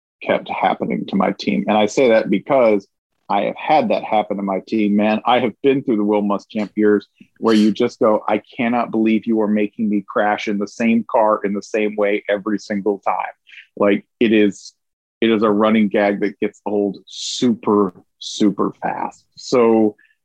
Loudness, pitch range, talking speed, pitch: -18 LUFS, 105-110 Hz, 195 wpm, 105 Hz